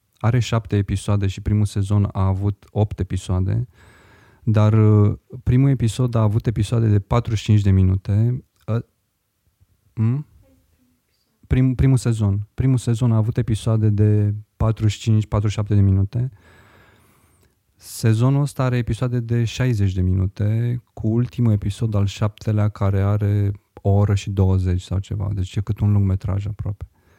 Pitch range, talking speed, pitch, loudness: 100-115 Hz, 130 wpm, 105 Hz, -20 LUFS